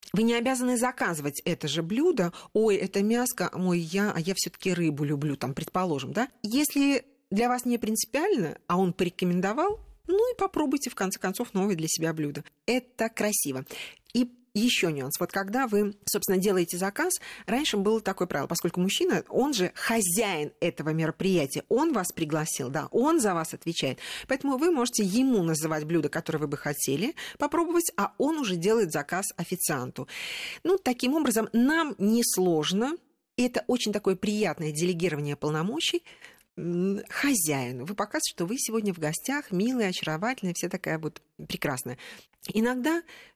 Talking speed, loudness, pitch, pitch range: 155 wpm, -28 LUFS, 200 Hz, 170-250 Hz